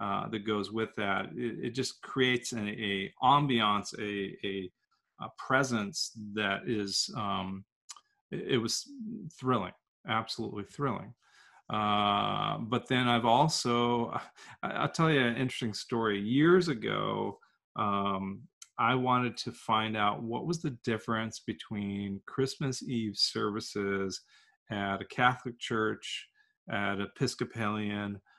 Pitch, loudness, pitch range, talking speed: 115 Hz, -31 LUFS, 105-125 Hz, 125 wpm